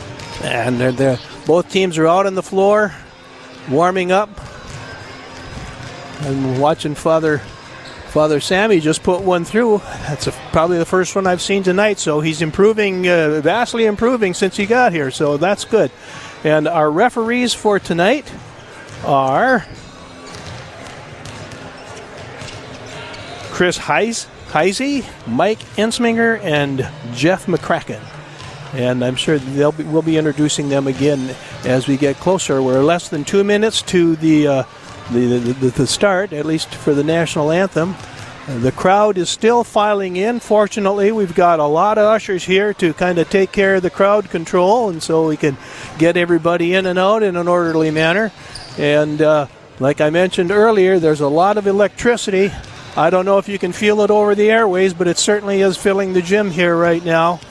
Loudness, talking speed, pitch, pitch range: -15 LUFS, 165 wpm, 170 Hz, 145-195 Hz